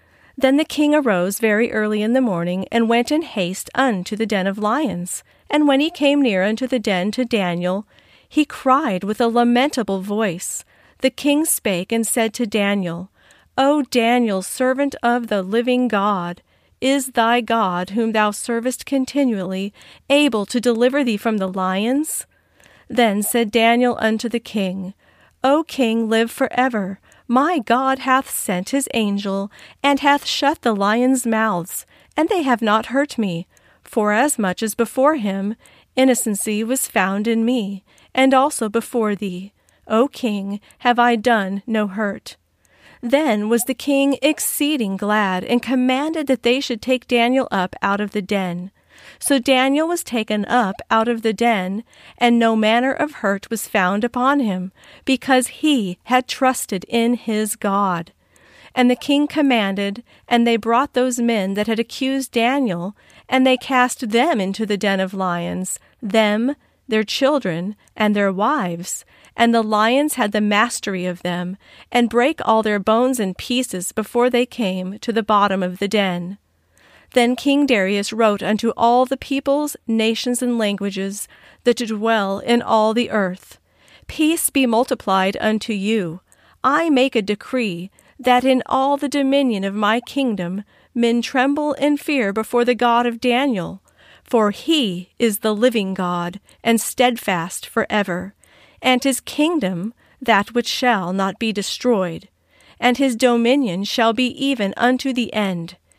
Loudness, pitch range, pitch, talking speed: -19 LUFS, 205-255 Hz, 230 Hz, 160 wpm